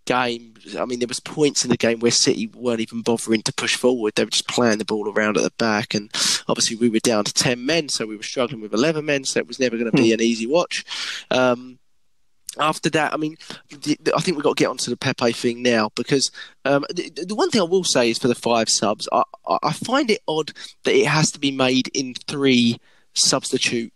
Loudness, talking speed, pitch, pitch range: -20 LUFS, 250 wpm, 125 Hz, 115-145 Hz